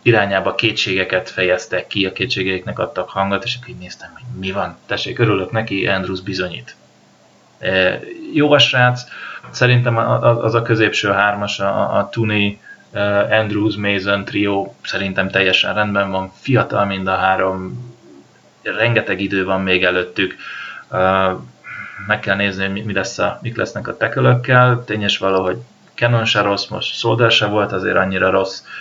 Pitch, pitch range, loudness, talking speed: 100 Hz, 95-110 Hz, -17 LUFS, 145 wpm